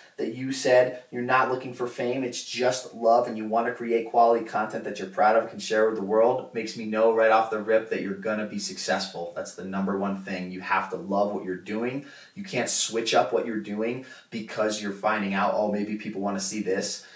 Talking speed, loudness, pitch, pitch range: 245 wpm, -26 LUFS, 110 Hz, 100-120 Hz